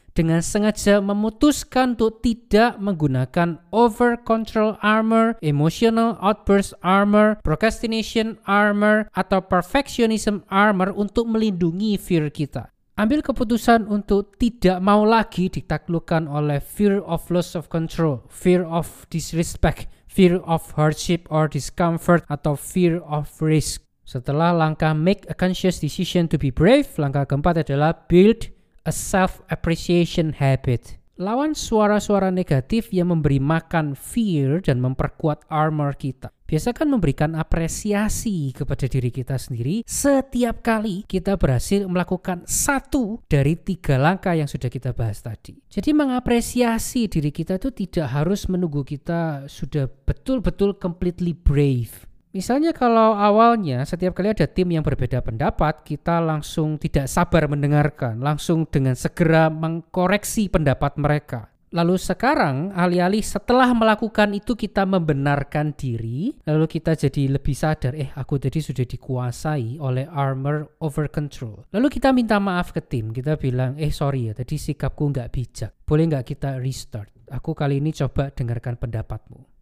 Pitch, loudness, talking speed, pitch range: 165 Hz, -21 LUFS, 135 wpm, 145-205 Hz